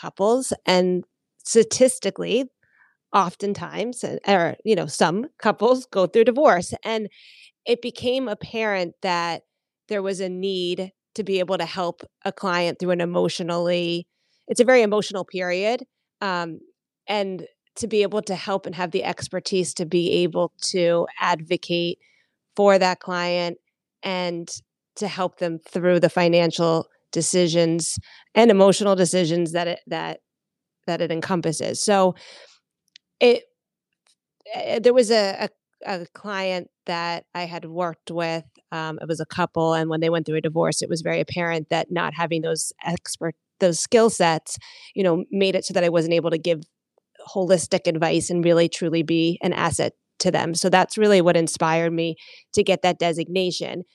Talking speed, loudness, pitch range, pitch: 155 wpm, -22 LUFS, 170-200 Hz, 180 Hz